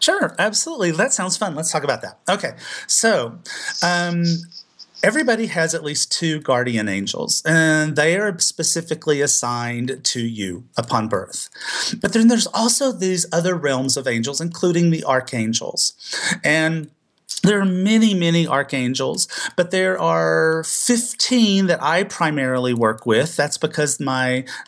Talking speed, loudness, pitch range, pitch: 140 wpm, -19 LUFS, 135-185 Hz, 160 Hz